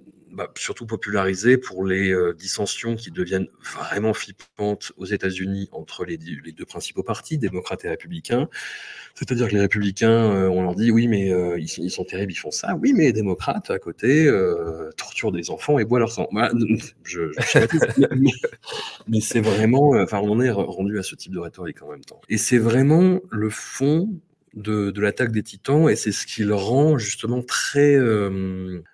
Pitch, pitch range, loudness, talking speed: 110 Hz, 95-130 Hz, -21 LUFS, 200 wpm